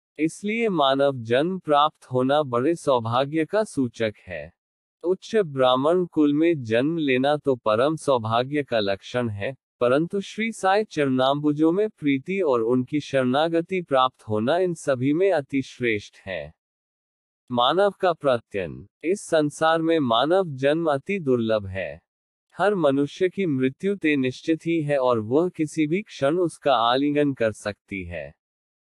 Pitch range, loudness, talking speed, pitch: 125-165 Hz, -23 LUFS, 140 wpm, 145 Hz